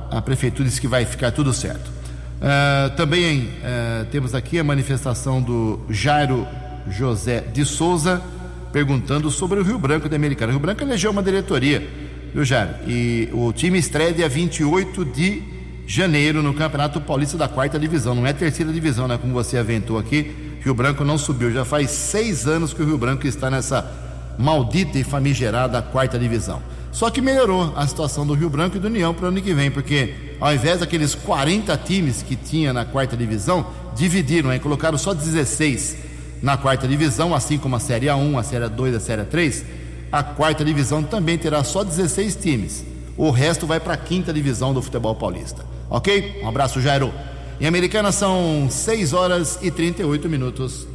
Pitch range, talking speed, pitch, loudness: 120-160 Hz, 180 wpm, 140 Hz, -20 LUFS